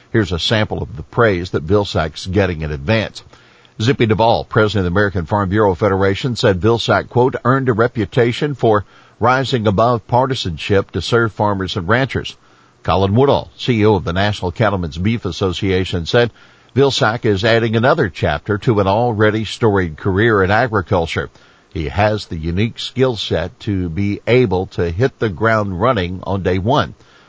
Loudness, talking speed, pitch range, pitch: -16 LUFS, 165 wpm, 95-120 Hz, 105 Hz